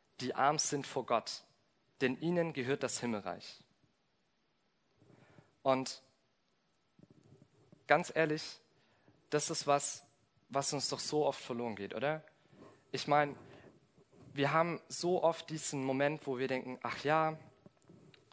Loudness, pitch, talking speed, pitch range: -35 LUFS, 140 Hz, 120 wpm, 130-155 Hz